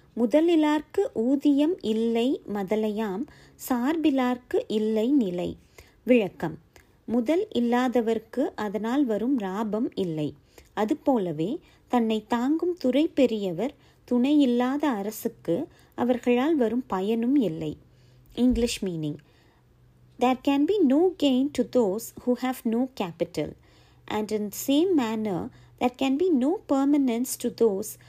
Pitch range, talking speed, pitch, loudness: 215-280 Hz, 105 wpm, 245 Hz, -26 LUFS